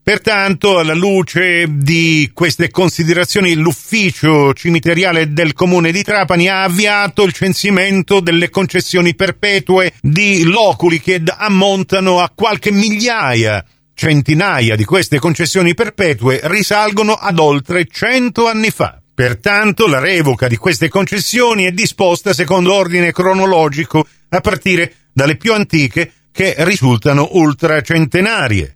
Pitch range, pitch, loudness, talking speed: 160-195 Hz, 180 Hz, -12 LUFS, 115 wpm